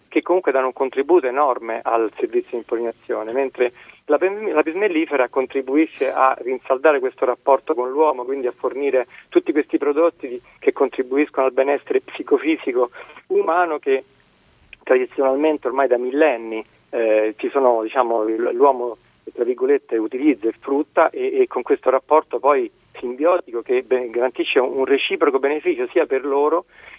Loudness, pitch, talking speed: -20 LUFS, 155 Hz, 140 wpm